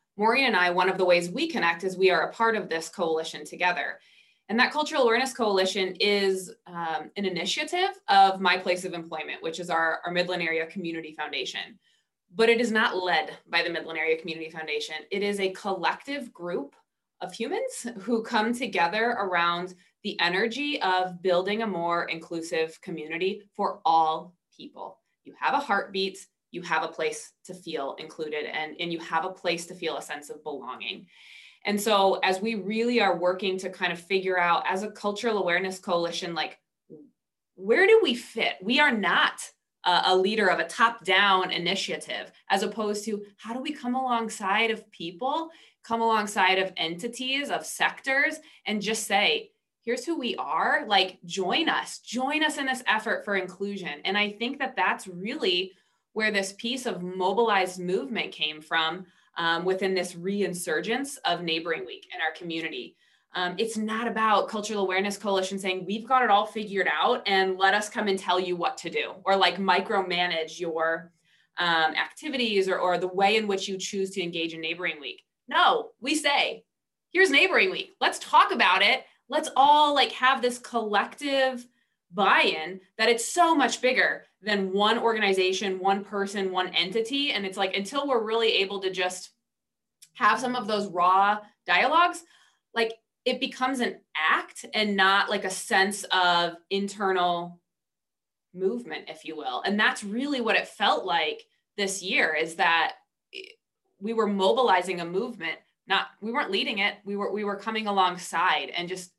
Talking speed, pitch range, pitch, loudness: 175 wpm, 180-230 Hz, 195 Hz, -26 LUFS